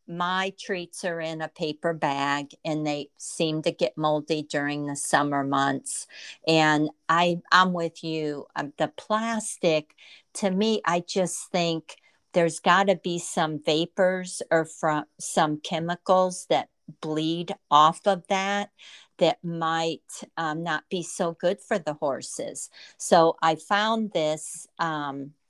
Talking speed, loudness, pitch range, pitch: 135 wpm, -26 LUFS, 155-185 Hz, 165 Hz